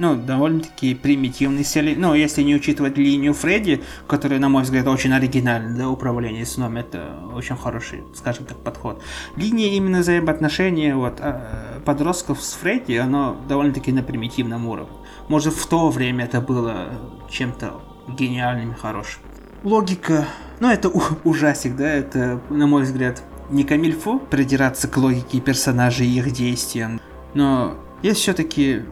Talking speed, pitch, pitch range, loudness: 145 wpm, 140 Hz, 125-150 Hz, -20 LUFS